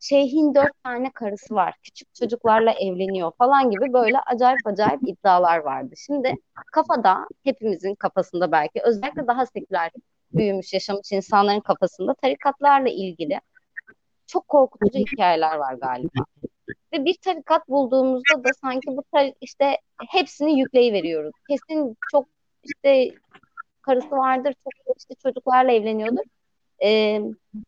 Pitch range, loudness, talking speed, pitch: 200-280 Hz, -21 LUFS, 120 wpm, 250 Hz